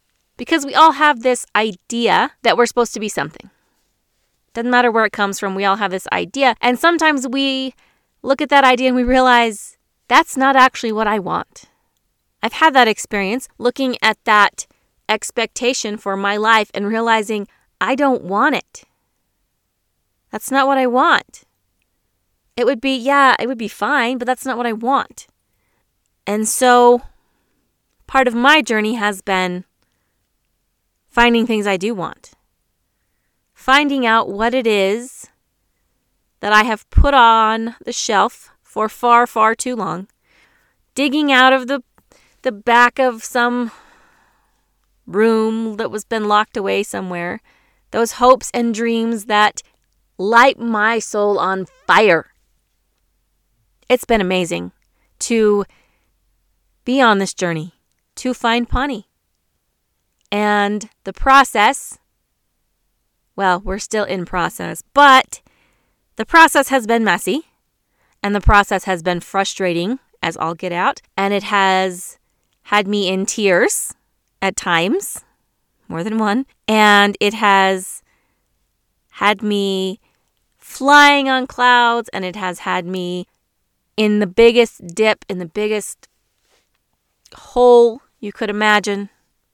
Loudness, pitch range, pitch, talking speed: -15 LUFS, 200-250 Hz, 220 Hz, 135 wpm